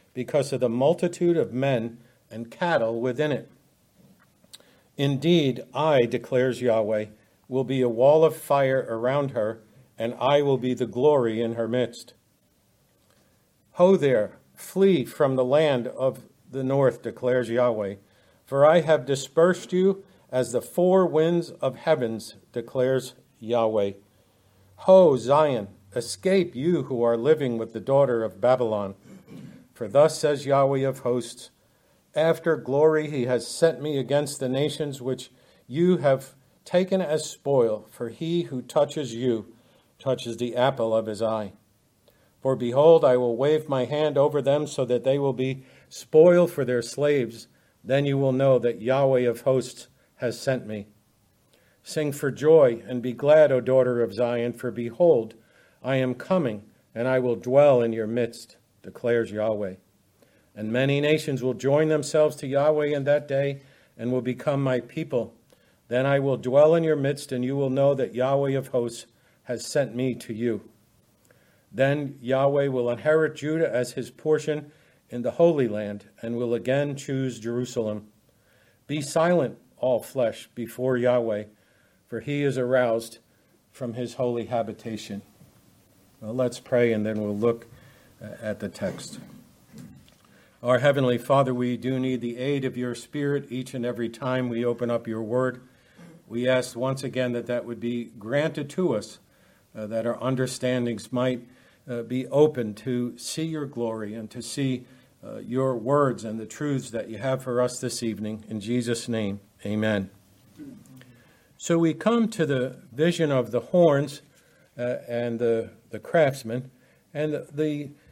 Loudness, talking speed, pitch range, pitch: -24 LUFS, 155 wpm, 115-140 Hz, 125 Hz